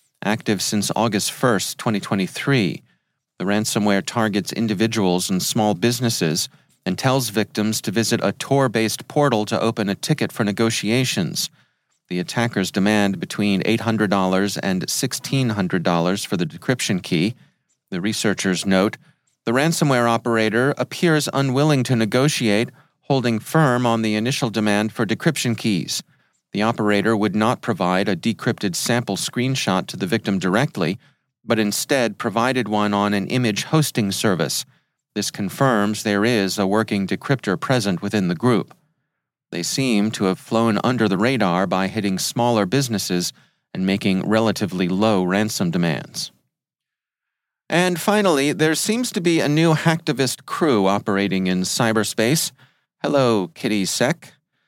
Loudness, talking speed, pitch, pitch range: -20 LUFS, 135 wpm, 110 Hz, 100-130 Hz